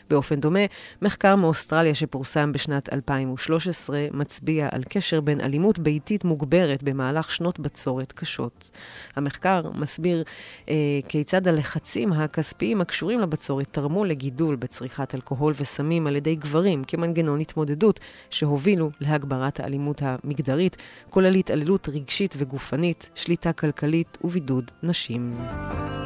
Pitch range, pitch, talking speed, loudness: 140-170 Hz, 150 Hz, 110 wpm, -25 LUFS